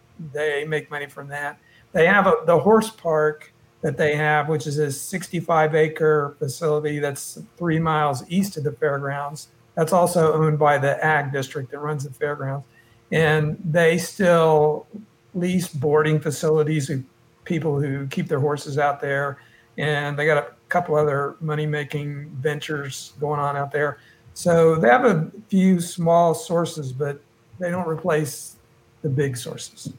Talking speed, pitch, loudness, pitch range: 155 wpm, 150 Hz, -22 LUFS, 145-160 Hz